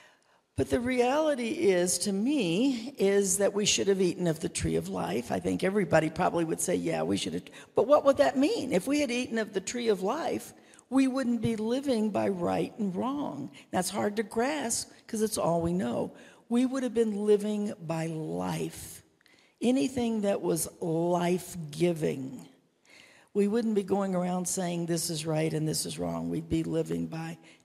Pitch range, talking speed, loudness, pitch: 160-235 Hz, 190 wpm, -29 LUFS, 195 Hz